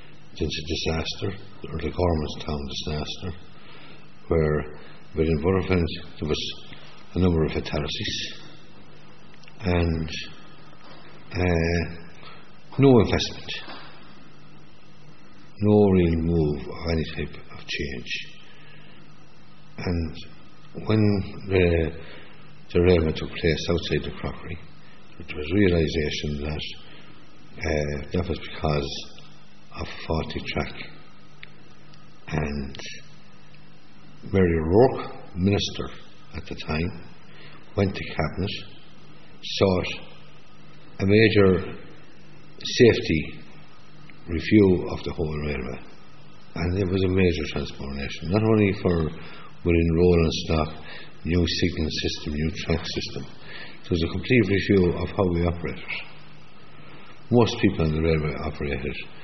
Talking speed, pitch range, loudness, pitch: 100 wpm, 75-95 Hz, -25 LUFS, 85 Hz